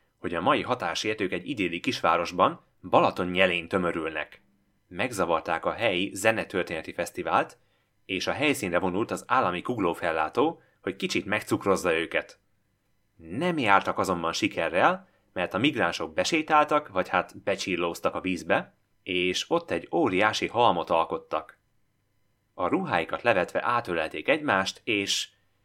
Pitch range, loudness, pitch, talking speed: 95-105 Hz, -26 LUFS, 100 Hz, 115 wpm